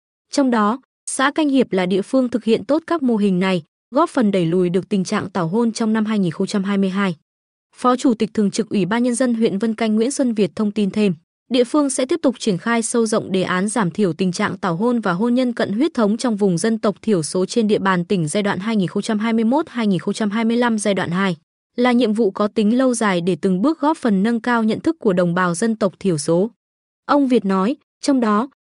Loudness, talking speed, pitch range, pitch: -19 LUFS, 235 wpm, 195-240 Hz, 220 Hz